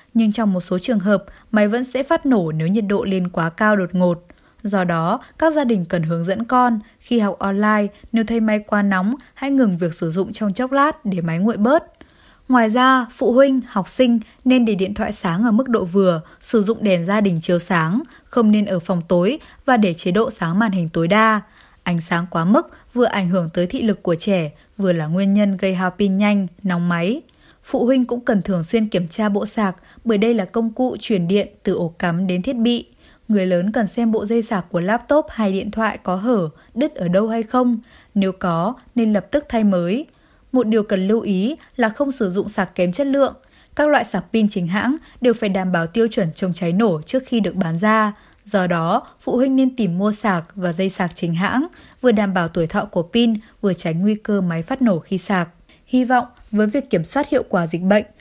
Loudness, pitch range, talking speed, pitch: -19 LUFS, 185-235 Hz, 235 wpm, 210 Hz